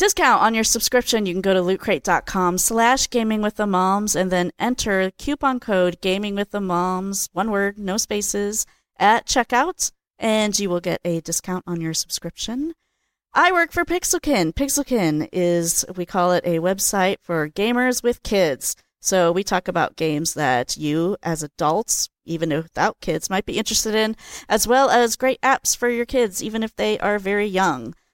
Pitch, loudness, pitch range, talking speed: 200 Hz, -20 LUFS, 180-240 Hz, 175 wpm